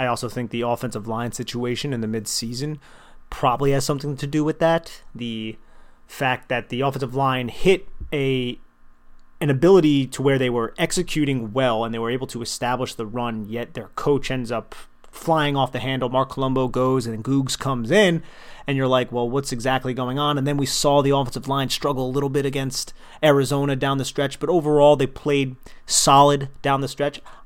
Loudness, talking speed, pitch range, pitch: -22 LUFS, 195 wpm, 120-145 Hz, 135 Hz